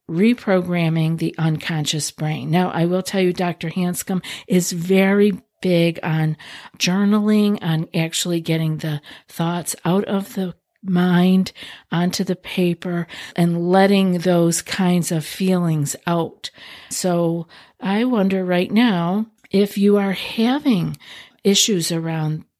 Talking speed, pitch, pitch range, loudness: 120 wpm, 180 Hz, 165-195 Hz, -19 LUFS